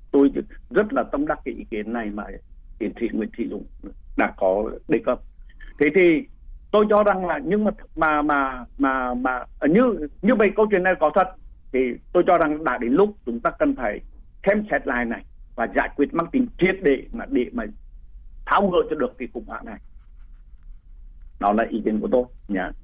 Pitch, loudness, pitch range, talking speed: 155 Hz, -22 LUFS, 125-210 Hz, 210 wpm